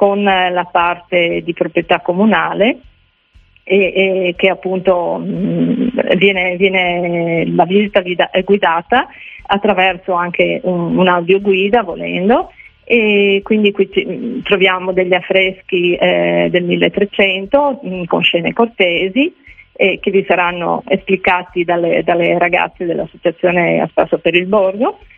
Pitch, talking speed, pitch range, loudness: 185 Hz, 120 wpm, 175-200 Hz, -14 LUFS